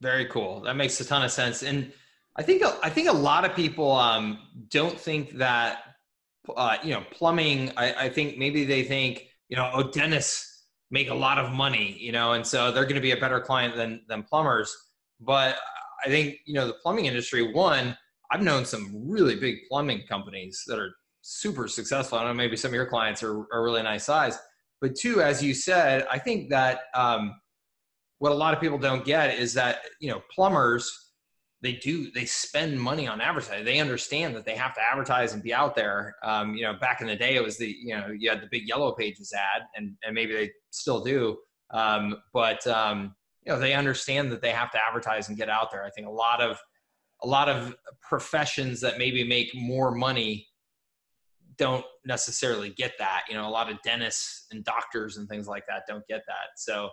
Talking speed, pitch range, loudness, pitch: 210 wpm, 110-140 Hz, -26 LUFS, 125 Hz